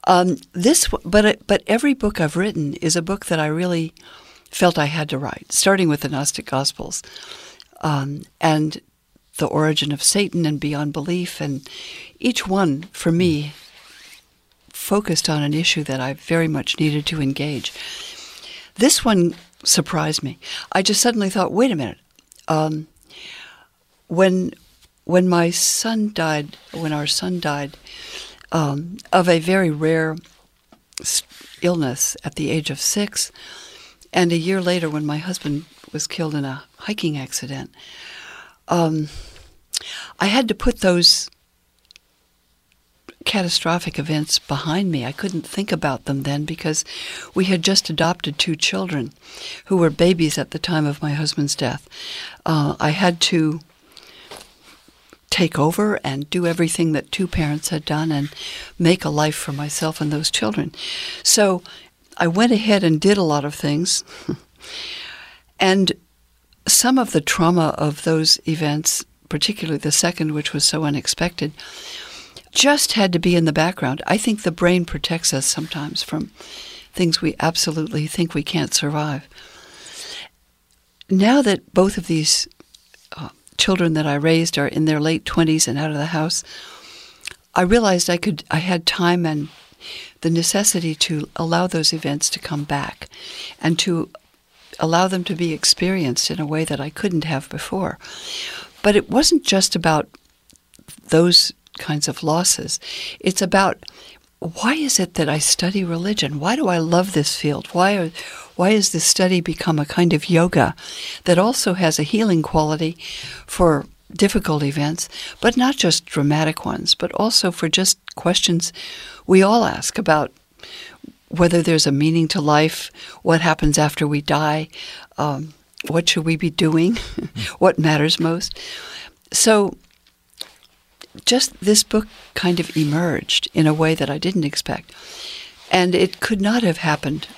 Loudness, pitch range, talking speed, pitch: -19 LUFS, 150-185 Hz, 150 wpm, 165 Hz